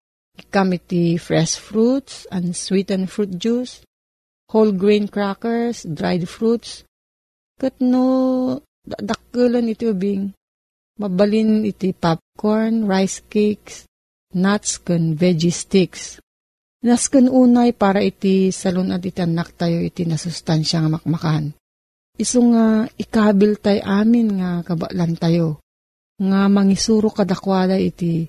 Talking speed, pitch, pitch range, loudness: 105 wpm, 195 Hz, 175-220 Hz, -18 LUFS